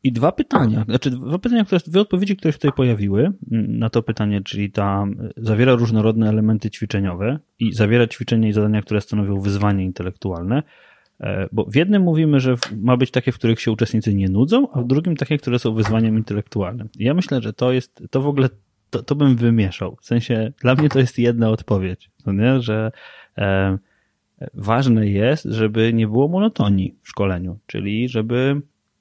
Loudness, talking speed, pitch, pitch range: -19 LUFS, 180 wpm, 115 Hz, 105-130 Hz